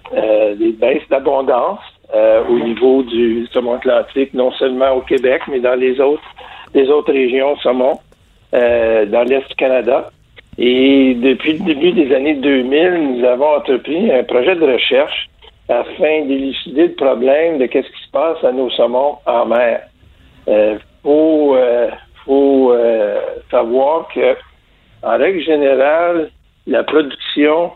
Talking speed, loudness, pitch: 145 wpm, -14 LUFS, 135 Hz